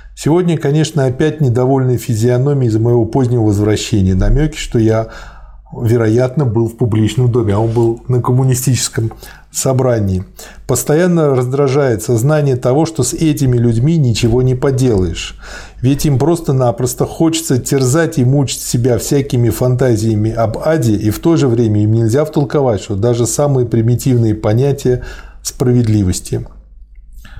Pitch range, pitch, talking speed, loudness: 115-140 Hz, 125 Hz, 130 wpm, -13 LUFS